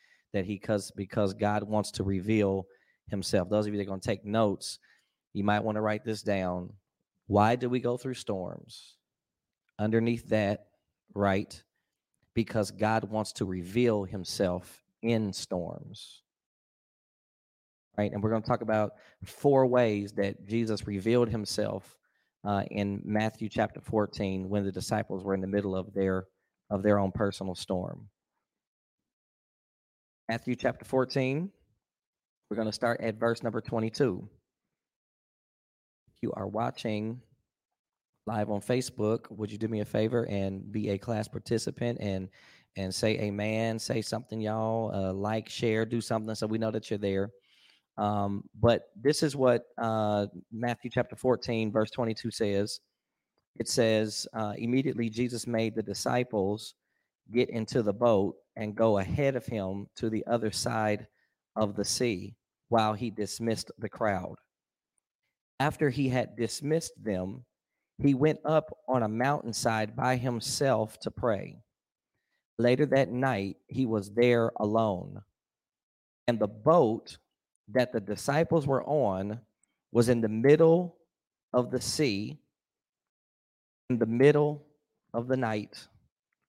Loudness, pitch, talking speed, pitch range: -30 LUFS, 110 Hz, 140 wpm, 100-120 Hz